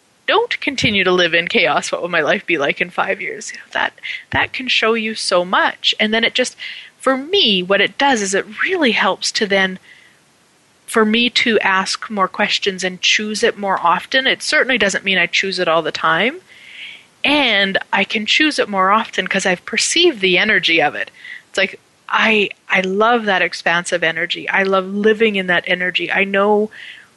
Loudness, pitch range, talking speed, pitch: -15 LUFS, 185-230 Hz, 200 wpm, 200 Hz